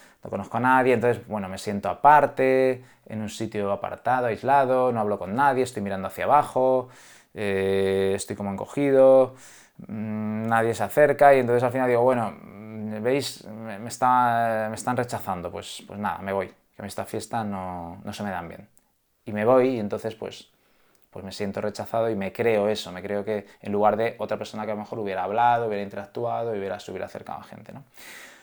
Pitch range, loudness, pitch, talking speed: 100-125 Hz, -24 LUFS, 110 Hz, 200 wpm